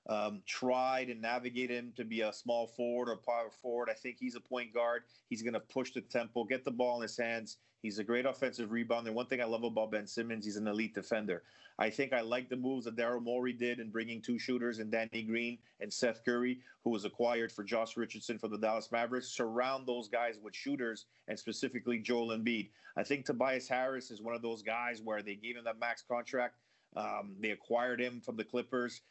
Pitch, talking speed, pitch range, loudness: 120 Hz, 225 wpm, 115-125 Hz, -38 LUFS